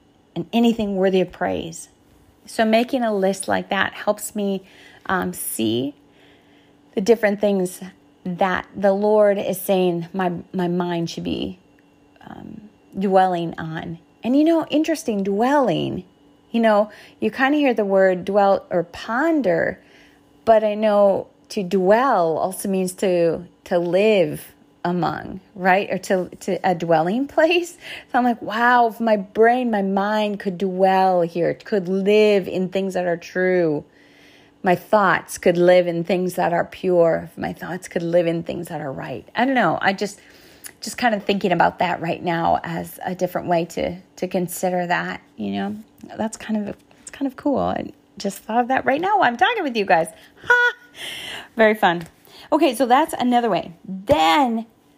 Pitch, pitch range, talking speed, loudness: 195 Hz, 180-225 Hz, 170 wpm, -20 LUFS